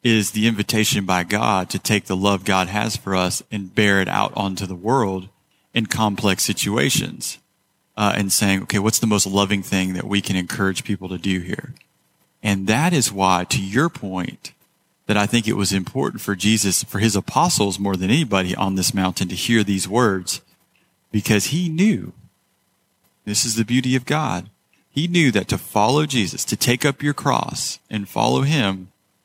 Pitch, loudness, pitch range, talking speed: 100 Hz, -20 LUFS, 95-115 Hz, 185 wpm